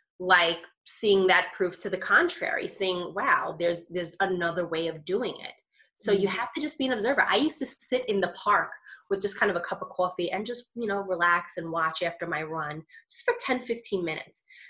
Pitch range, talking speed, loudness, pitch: 175-235 Hz, 220 wpm, -27 LUFS, 185 Hz